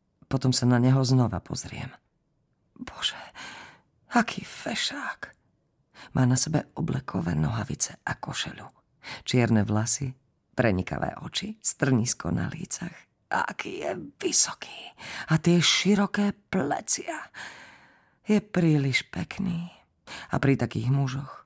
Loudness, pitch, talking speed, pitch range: -26 LUFS, 135 Hz, 105 wpm, 125-175 Hz